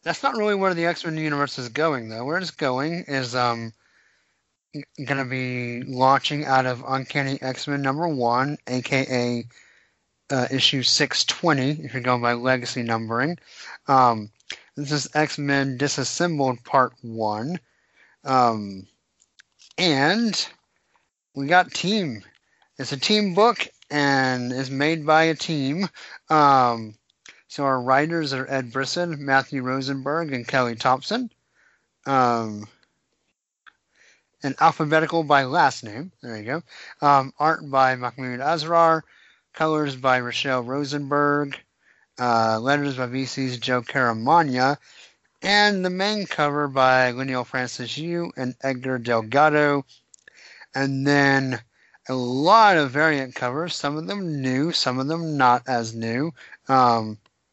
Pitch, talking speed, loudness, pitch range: 135 Hz, 130 wpm, -22 LUFS, 125-155 Hz